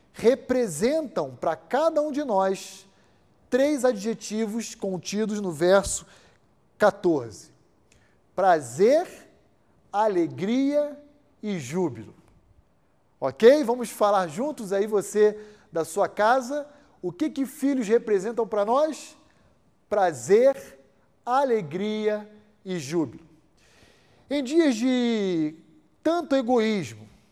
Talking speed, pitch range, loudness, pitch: 90 wpm, 190-270 Hz, -25 LUFS, 215 Hz